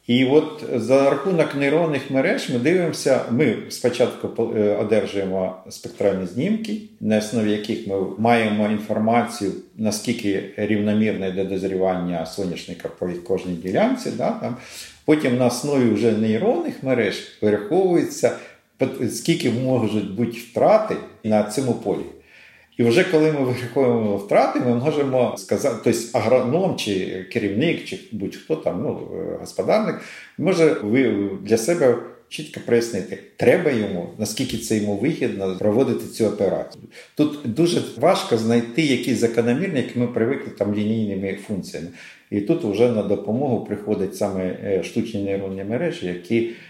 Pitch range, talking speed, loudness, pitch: 100-125 Hz, 125 wpm, -21 LUFS, 115 Hz